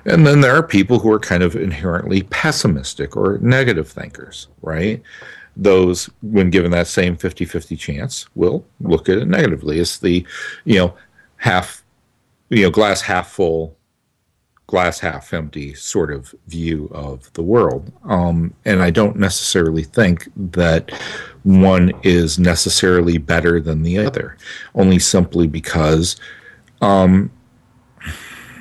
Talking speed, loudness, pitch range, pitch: 135 wpm, -16 LUFS, 85-95 Hz, 90 Hz